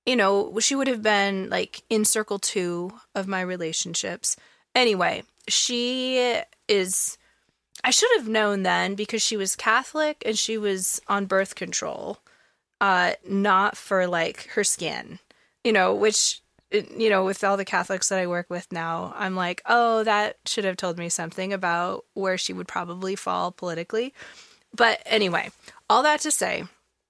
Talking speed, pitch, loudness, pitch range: 160 wpm, 200 Hz, -24 LUFS, 185-225 Hz